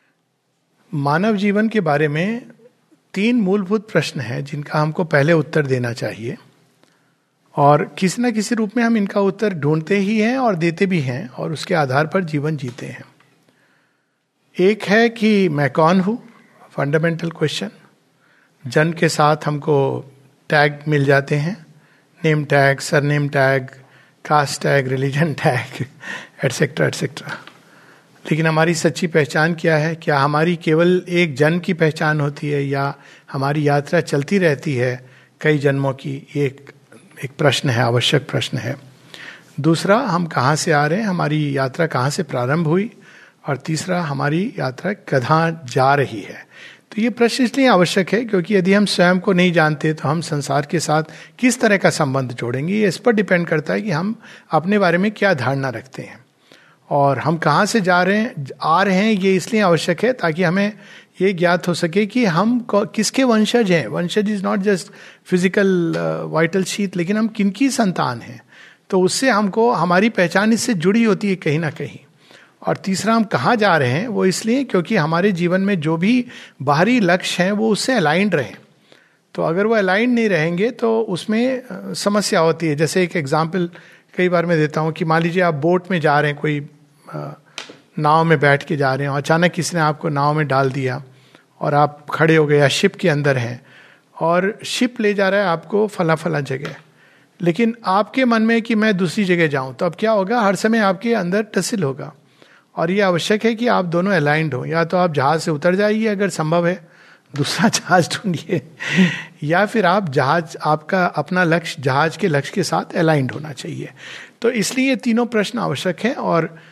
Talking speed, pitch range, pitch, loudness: 180 wpm, 150-200 Hz, 170 Hz, -18 LUFS